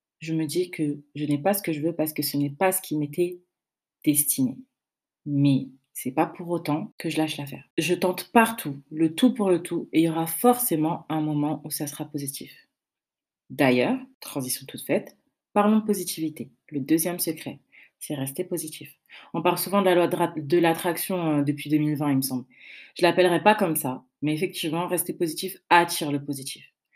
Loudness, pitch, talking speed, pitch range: -25 LUFS, 160 Hz, 195 wpm, 145-180 Hz